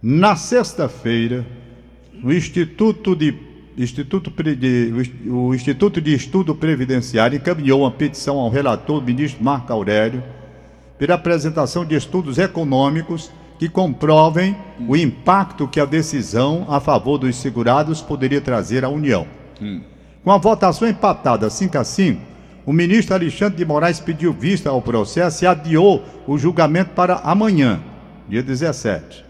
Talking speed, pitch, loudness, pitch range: 130 wpm, 150 Hz, -18 LUFS, 130-175 Hz